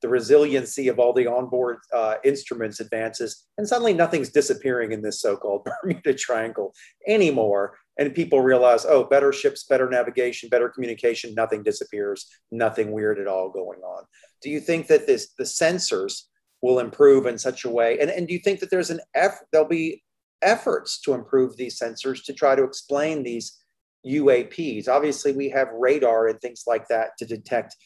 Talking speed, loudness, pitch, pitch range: 175 wpm, -22 LUFS, 135 Hz, 120-180 Hz